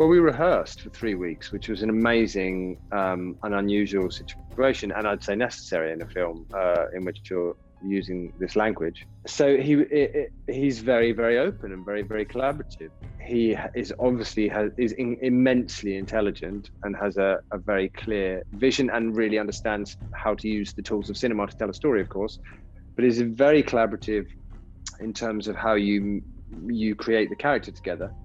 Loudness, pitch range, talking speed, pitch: -25 LUFS, 95-115 Hz, 180 wpm, 105 Hz